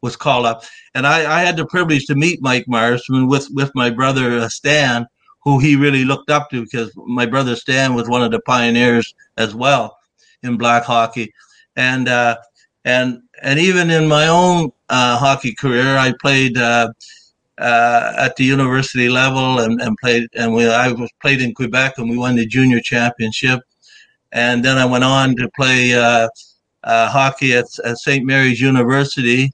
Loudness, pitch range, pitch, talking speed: -15 LUFS, 120-135 Hz, 125 Hz, 175 wpm